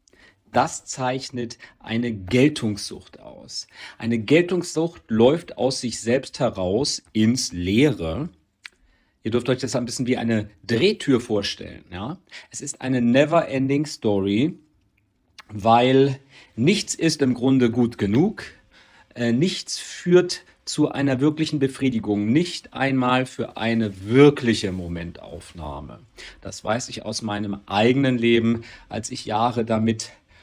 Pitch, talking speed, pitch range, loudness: 120 Hz, 120 wpm, 110-135 Hz, -22 LUFS